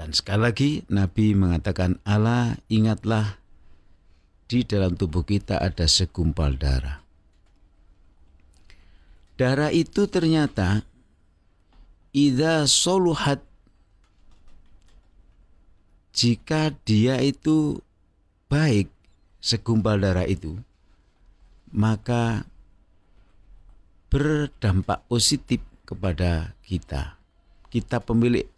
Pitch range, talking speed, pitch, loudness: 80-115 Hz, 70 wpm, 95 Hz, -23 LUFS